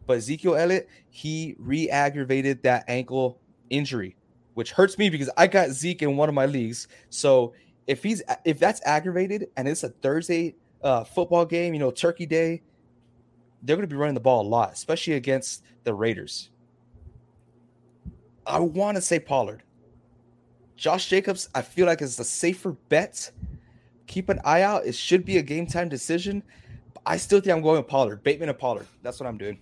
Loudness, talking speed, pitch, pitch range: -25 LUFS, 180 wpm, 140 Hz, 120-170 Hz